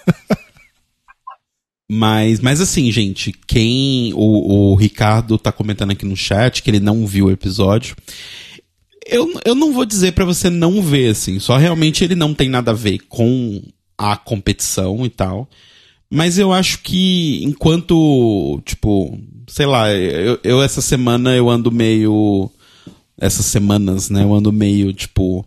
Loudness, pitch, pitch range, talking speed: -15 LUFS, 110 Hz, 100-140 Hz, 150 wpm